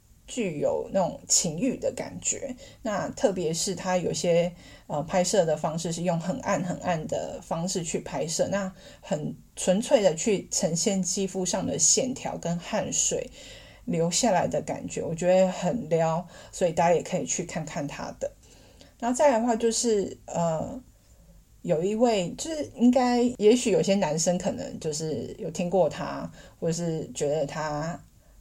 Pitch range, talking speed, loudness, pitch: 170-225 Hz, 230 characters per minute, -26 LUFS, 185 Hz